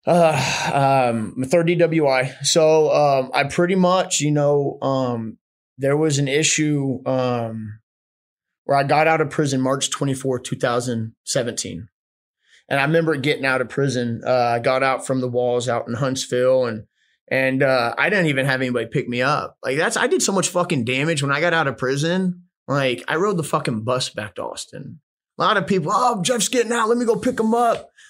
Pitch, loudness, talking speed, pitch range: 140 Hz, -20 LUFS, 190 wpm, 125-165 Hz